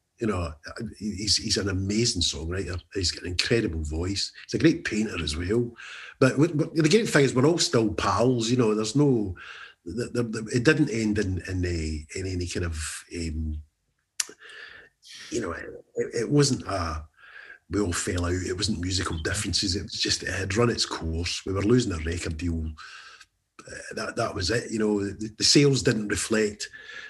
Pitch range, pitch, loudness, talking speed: 90-120 Hz, 105 Hz, -26 LUFS, 185 wpm